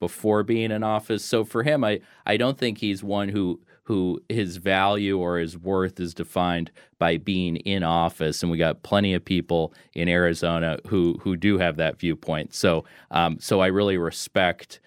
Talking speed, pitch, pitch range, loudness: 185 wpm, 90 Hz, 85-100 Hz, -24 LUFS